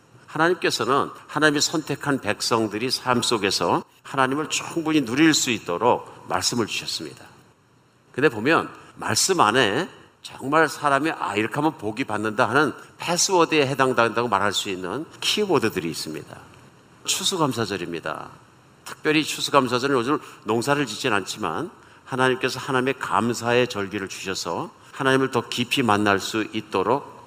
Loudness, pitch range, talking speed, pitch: -22 LUFS, 110-145 Hz, 330 characters per minute, 130 Hz